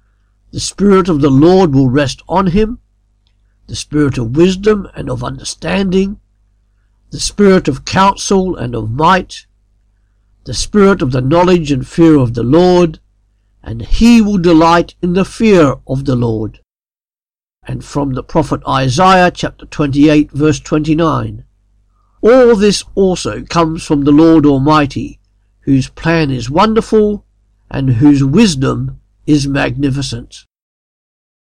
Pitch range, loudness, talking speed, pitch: 115-175 Hz, -11 LUFS, 130 wpm, 145 Hz